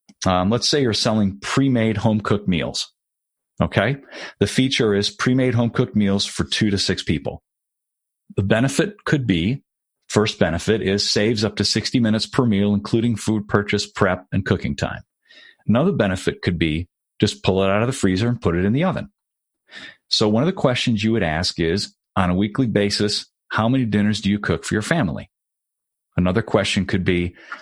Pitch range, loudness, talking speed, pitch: 100-115 Hz, -20 LUFS, 185 wpm, 105 Hz